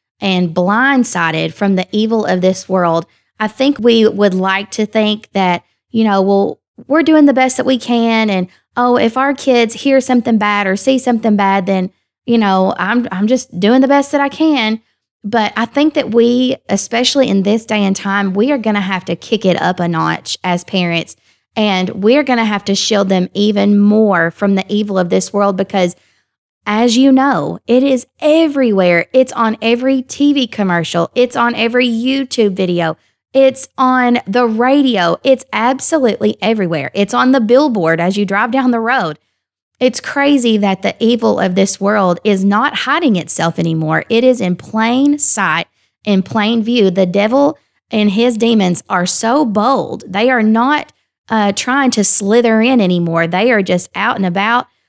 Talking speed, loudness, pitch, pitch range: 185 wpm, -13 LUFS, 220 Hz, 195-250 Hz